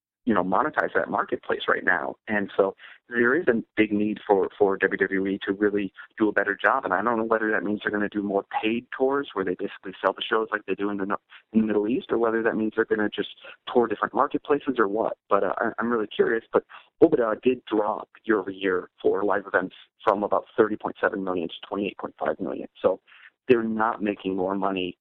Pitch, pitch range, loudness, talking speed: 105 Hz, 95-115 Hz, -25 LUFS, 220 wpm